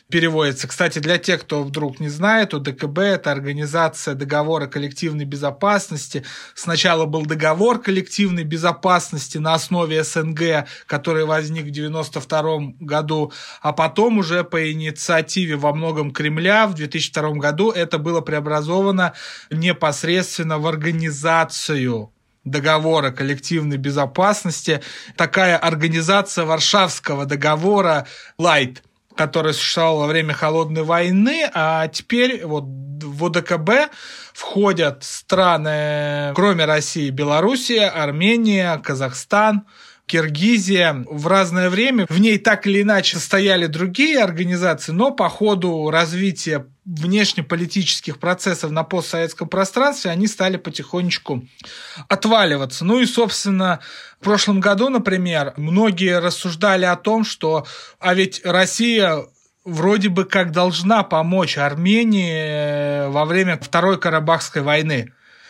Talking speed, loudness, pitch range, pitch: 110 wpm, -18 LUFS, 150-190 Hz, 165 Hz